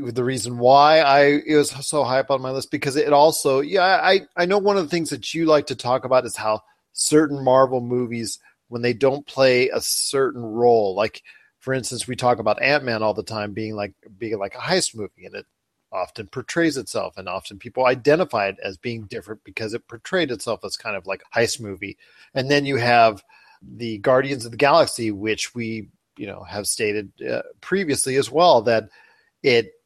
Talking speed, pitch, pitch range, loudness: 205 wpm, 130 Hz, 115-145 Hz, -20 LUFS